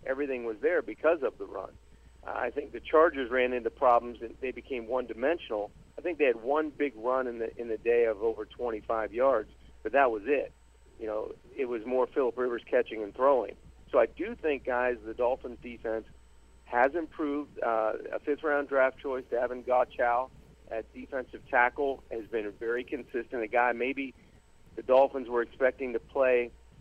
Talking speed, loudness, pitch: 185 wpm, -30 LUFS, 130 Hz